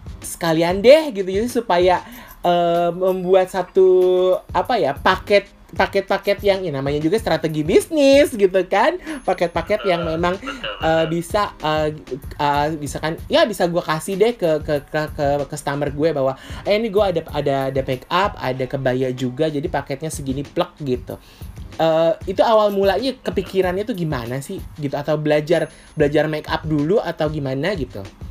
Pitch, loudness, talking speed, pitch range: 165 Hz, -19 LUFS, 155 wpm, 145-195 Hz